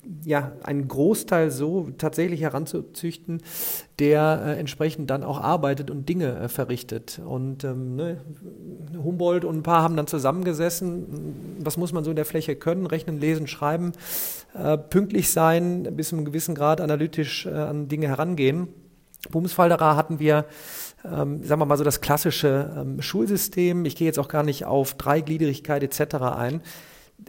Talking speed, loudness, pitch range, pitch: 160 wpm, -24 LUFS, 145-170 Hz, 155 Hz